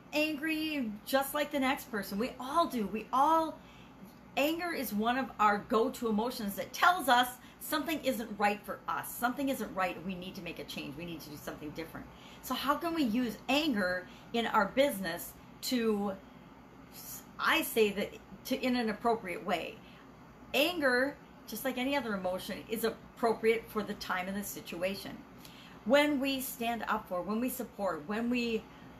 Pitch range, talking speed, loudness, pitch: 205-270 Hz, 170 wpm, -33 LUFS, 235 Hz